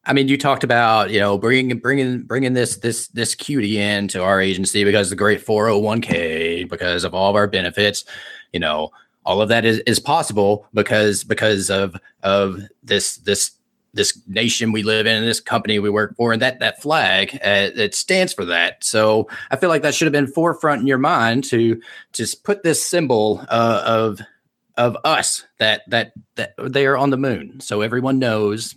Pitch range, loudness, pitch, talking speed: 105-130 Hz, -18 LUFS, 110 Hz, 195 wpm